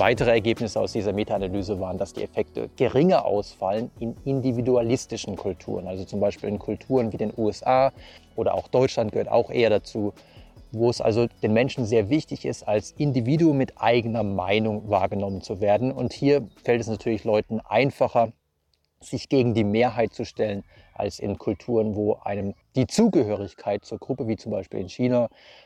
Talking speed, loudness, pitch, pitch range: 170 wpm, -24 LUFS, 110 Hz, 100-120 Hz